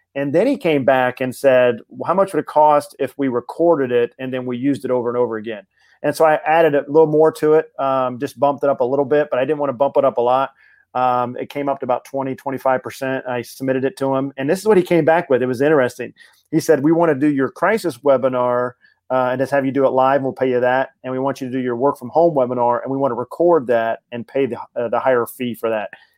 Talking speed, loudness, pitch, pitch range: 285 wpm, -18 LUFS, 135 Hz, 125-150 Hz